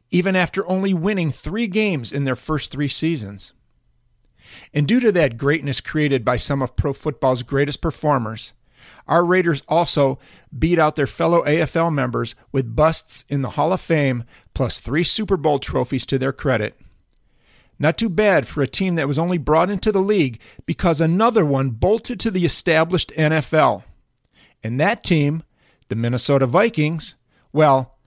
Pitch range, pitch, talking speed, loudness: 135-170 Hz, 150 Hz, 160 wpm, -19 LUFS